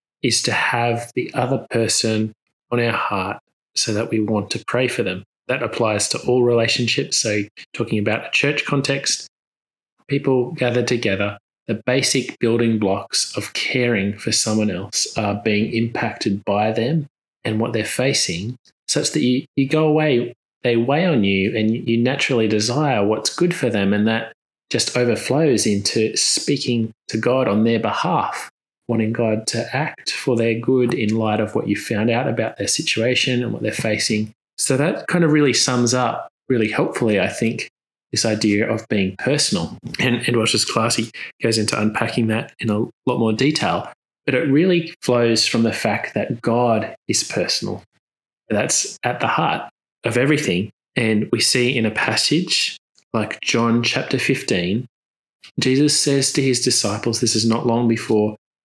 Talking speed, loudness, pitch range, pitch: 170 wpm, -19 LUFS, 110-125 Hz, 115 Hz